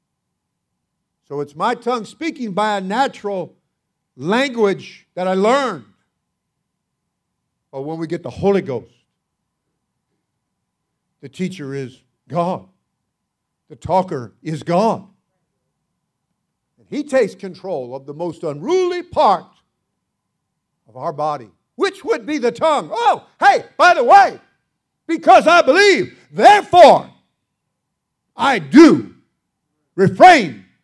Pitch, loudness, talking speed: 195 Hz, -15 LUFS, 105 wpm